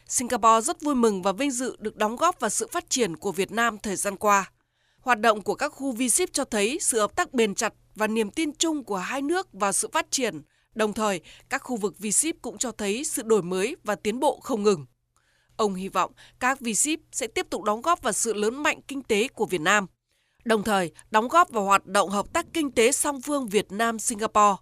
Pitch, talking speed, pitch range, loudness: 225 Hz, 240 wpm, 205-275 Hz, -25 LUFS